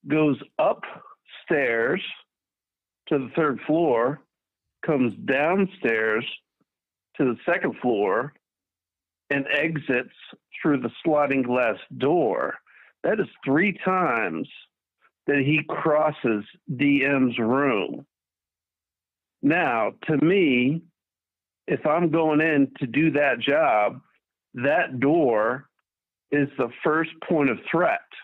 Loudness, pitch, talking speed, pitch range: -23 LUFS, 140 Hz, 100 wpm, 105-155 Hz